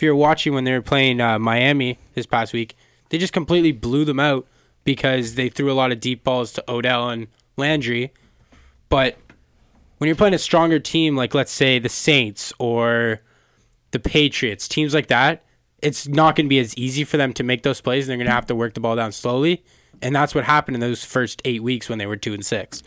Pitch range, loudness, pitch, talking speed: 120-150 Hz, -20 LUFS, 130 Hz, 230 wpm